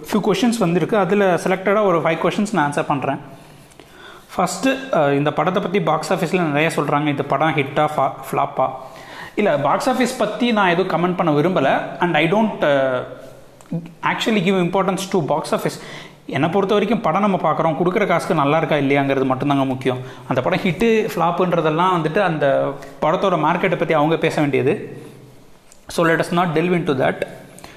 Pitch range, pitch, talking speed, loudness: 145-190 Hz, 165 Hz, 160 wpm, -18 LUFS